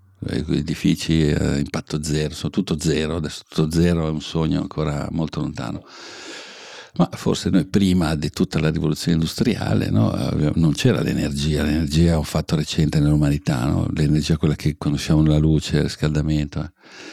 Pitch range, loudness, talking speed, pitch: 75-80 Hz, -21 LUFS, 160 wpm, 75 Hz